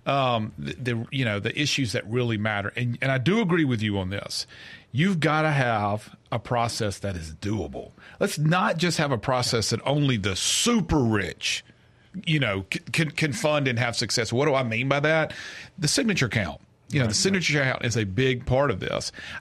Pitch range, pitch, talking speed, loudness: 110-150 Hz, 125 Hz, 205 wpm, -25 LUFS